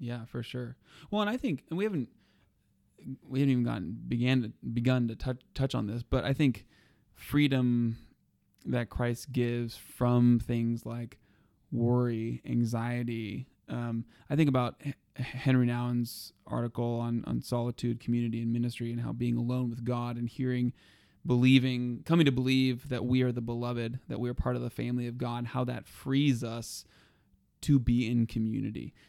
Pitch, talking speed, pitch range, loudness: 120 Hz, 170 wpm, 115-130 Hz, -31 LUFS